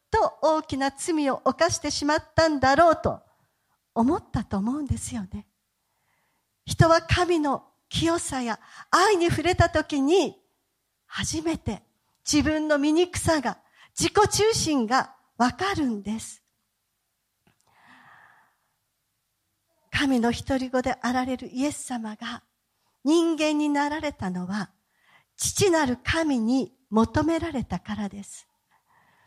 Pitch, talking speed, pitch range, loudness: 290 Hz, 225 characters per minute, 245-325 Hz, -24 LUFS